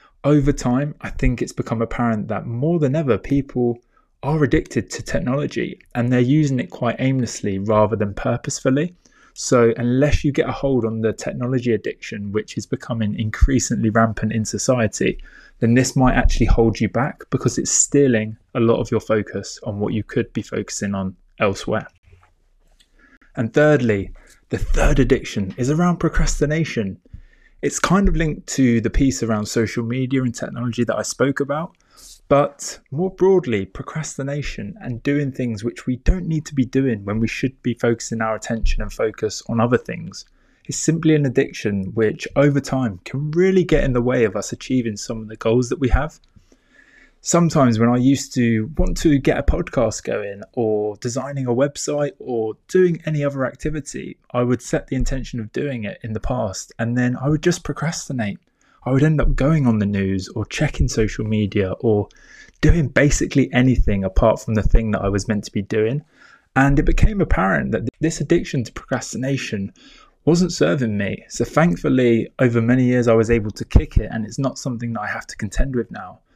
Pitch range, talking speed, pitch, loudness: 110-140 Hz, 185 wpm, 125 Hz, -20 LUFS